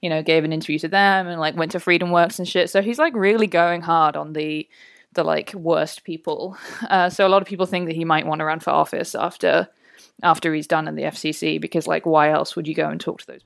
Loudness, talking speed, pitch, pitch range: -20 LUFS, 270 wpm, 165 Hz, 155-190 Hz